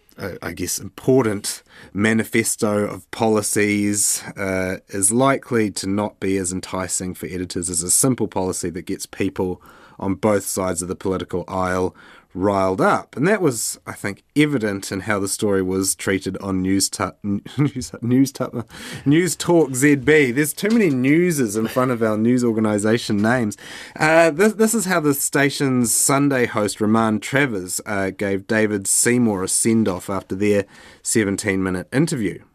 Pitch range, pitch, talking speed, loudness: 95-130 Hz, 105 Hz, 165 wpm, -20 LUFS